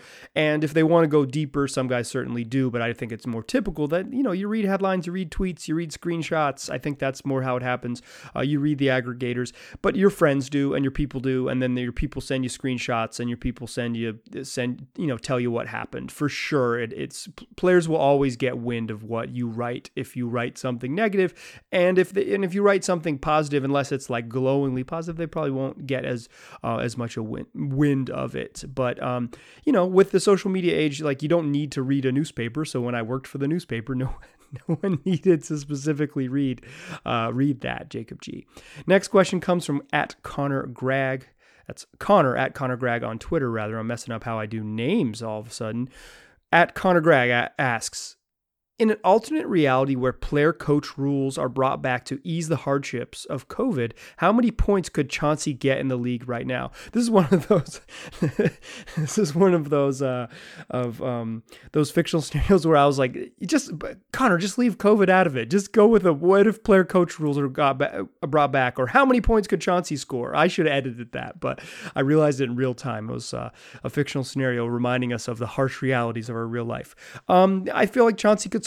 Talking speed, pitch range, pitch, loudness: 225 wpm, 125-170 Hz, 140 Hz, -24 LUFS